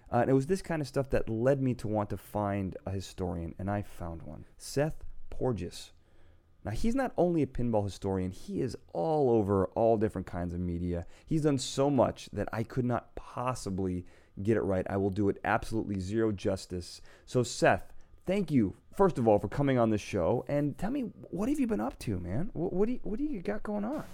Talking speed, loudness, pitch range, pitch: 225 wpm, -31 LUFS, 95-140 Hz, 105 Hz